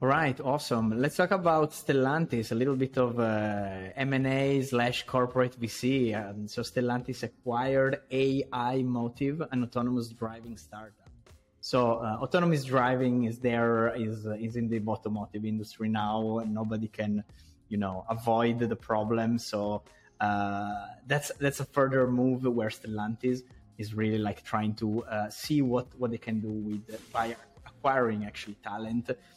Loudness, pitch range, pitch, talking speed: -30 LUFS, 110-130 Hz, 115 Hz, 150 wpm